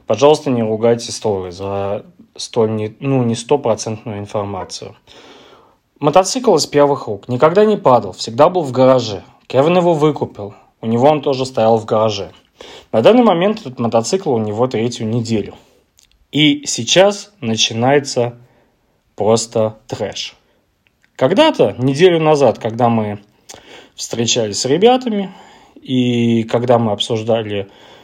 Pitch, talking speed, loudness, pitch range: 120 Hz, 120 wpm, -15 LUFS, 110-150 Hz